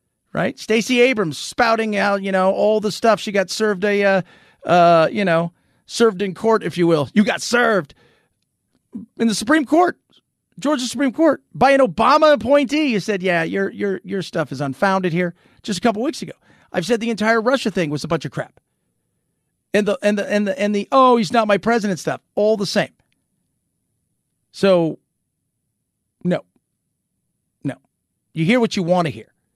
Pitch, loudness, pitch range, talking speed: 205 Hz, -18 LUFS, 185-230 Hz, 190 wpm